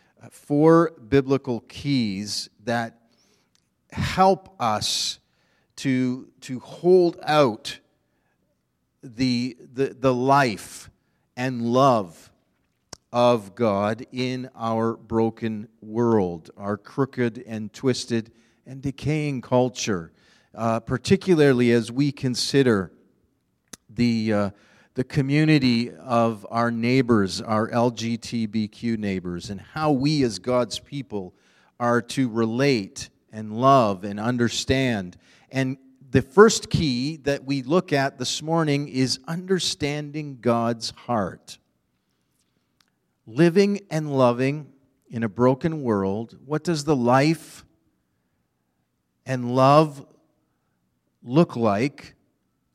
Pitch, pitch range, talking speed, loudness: 125 Hz, 115-140 Hz, 100 wpm, -23 LUFS